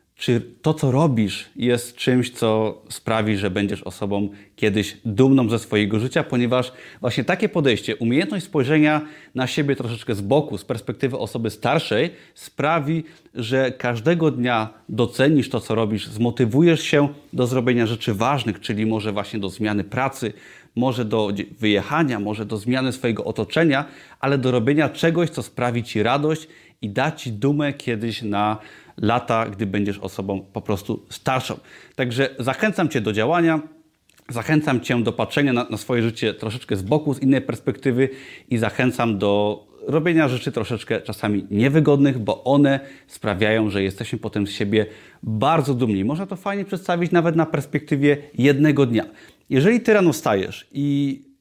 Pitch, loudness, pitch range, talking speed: 125 Hz, -21 LUFS, 110-145 Hz, 150 wpm